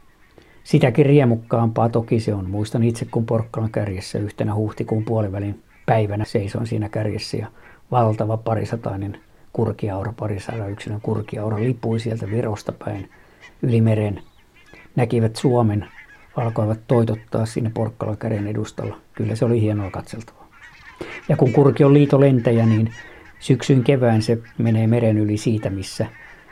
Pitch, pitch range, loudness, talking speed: 115 Hz, 105-120 Hz, -21 LUFS, 130 wpm